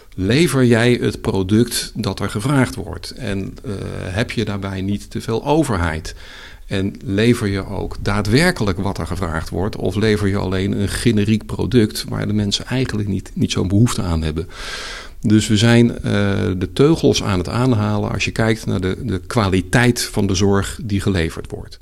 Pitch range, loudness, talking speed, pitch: 95-115 Hz, -18 LUFS, 180 wpm, 105 Hz